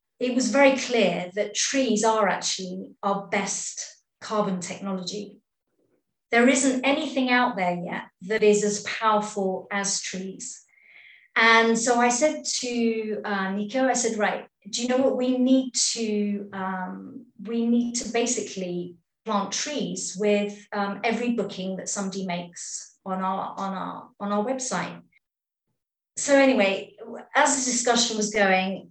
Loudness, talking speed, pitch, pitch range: -24 LUFS, 145 wpm, 210 Hz, 195-245 Hz